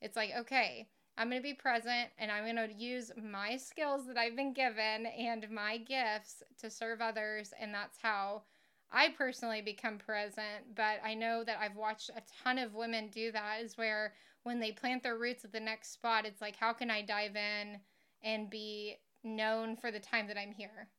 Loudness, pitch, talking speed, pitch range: -38 LUFS, 225 Hz, 195 wpm, 215-235 Hz